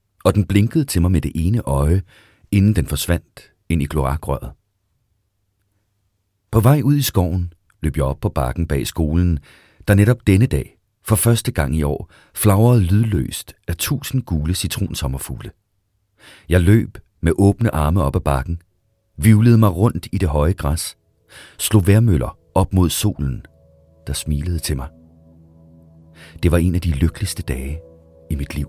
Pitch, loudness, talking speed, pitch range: 90 Hz, -18 LUFS, 160 wpm, 80-105 Hz